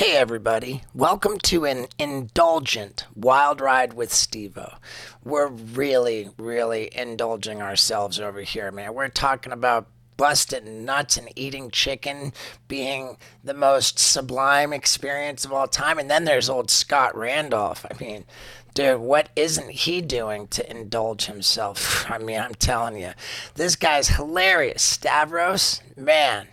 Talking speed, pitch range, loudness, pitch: 135 wpm, 115-140 Hz, -22 LUFS, 130 Hz